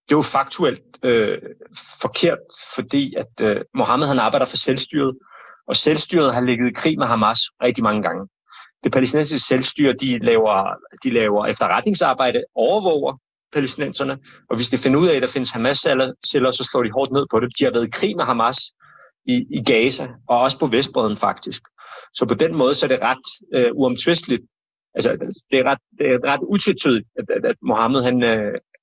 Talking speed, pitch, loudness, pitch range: 185 wpm, 135 Hz, -19 LUFS, 125-155 Hz